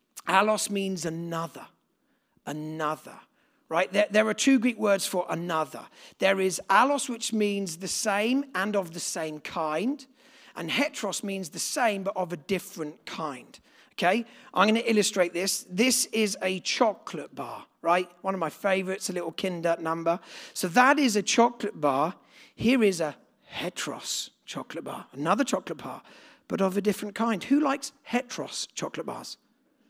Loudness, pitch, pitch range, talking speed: -27 LUFS, 195 Hz, 175-230 Hz, 160 wpm